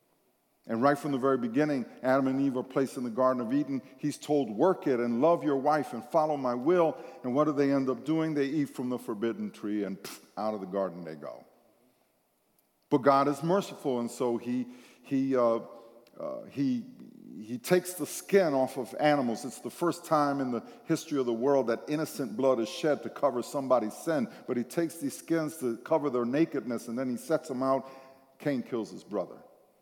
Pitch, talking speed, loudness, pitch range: 135 Hz, 210 wpm, -30 LUFS, 125-155 Hz